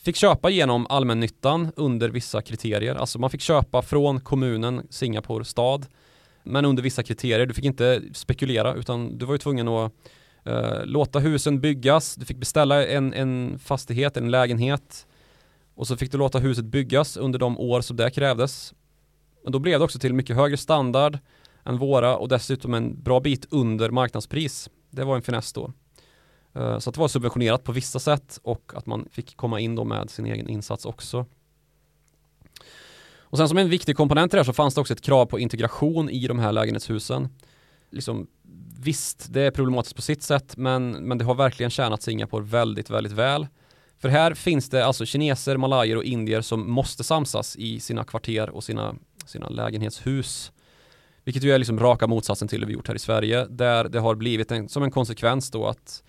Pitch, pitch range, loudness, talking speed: 130 Hz, 115-140 Hz, -24 LUFS, 190 wpm